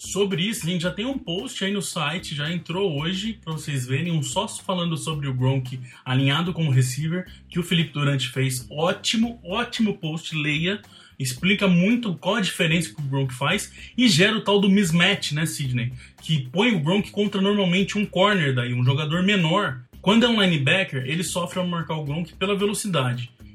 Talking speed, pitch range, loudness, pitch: 195 wpm, 145-195 Hz, -23 LUFS, 175 Hz